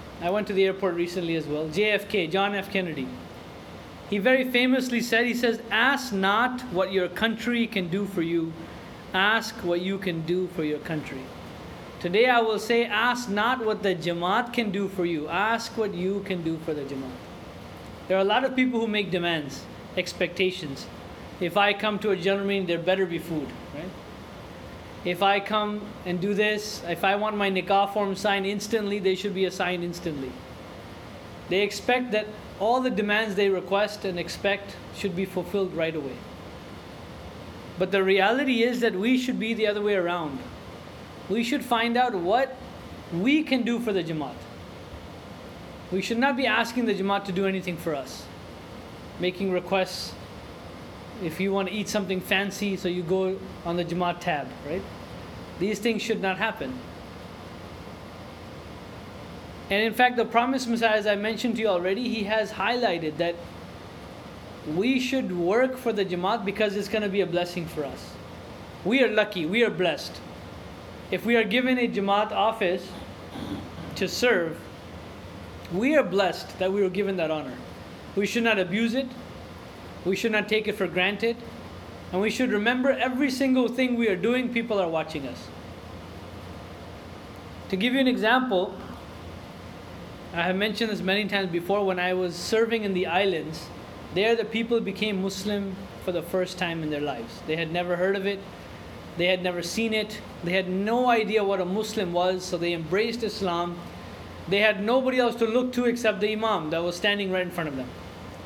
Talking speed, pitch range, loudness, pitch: 180 wpm, 165-215 Hz, -26 LUFS, 190 Hz